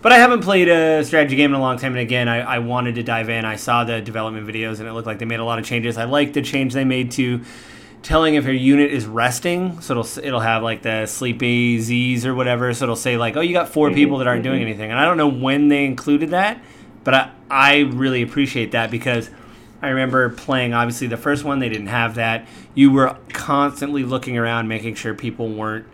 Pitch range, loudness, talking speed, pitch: 115-140 Hz, -18 LUFS, 245 wpm, 125 Hz